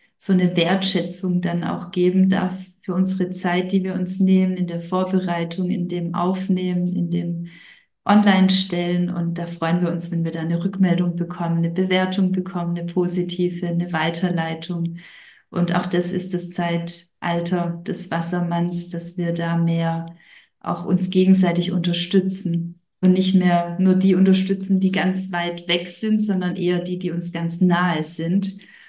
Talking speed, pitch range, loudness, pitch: 160 wpm, 170-185 Hz, -21 LUFS, 180 Hz